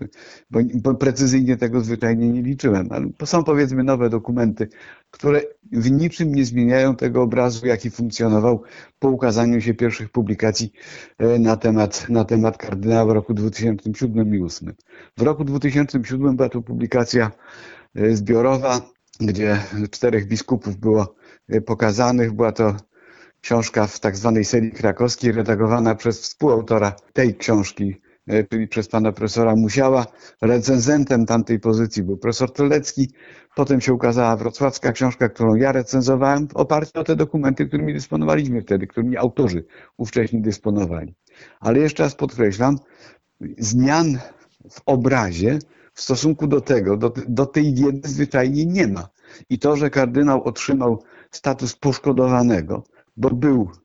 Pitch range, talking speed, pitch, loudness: 110-135 Hz, 130 wpm, 120 Hz, -19 LUFS